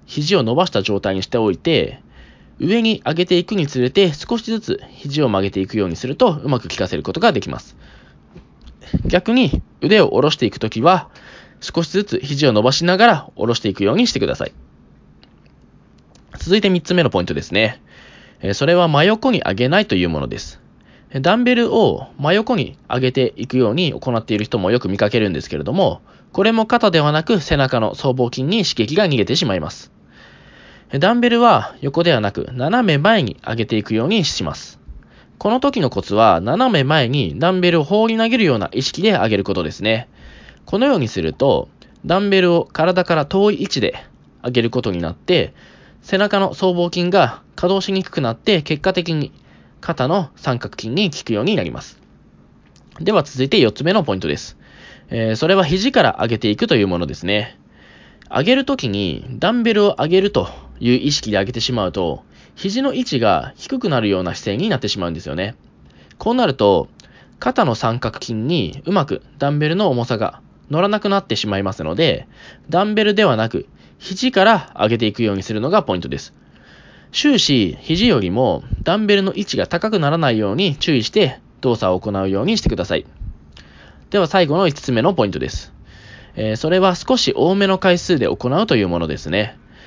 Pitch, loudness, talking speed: 145 Hz, -17 LUFS, 360 characters per minute